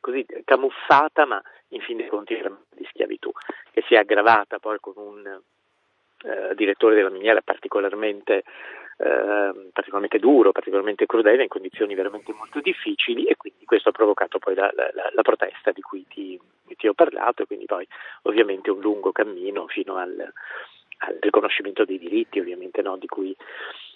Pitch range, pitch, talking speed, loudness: 360-440 Hz, 390 Hz, 165 wpm, -22 LUFS